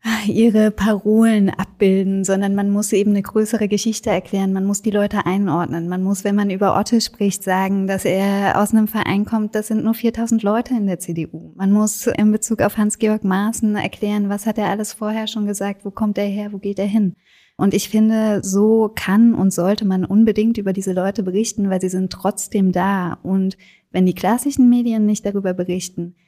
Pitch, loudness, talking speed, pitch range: 205 Hz, -18 LUFS, 200 wpm, 195-215 Hz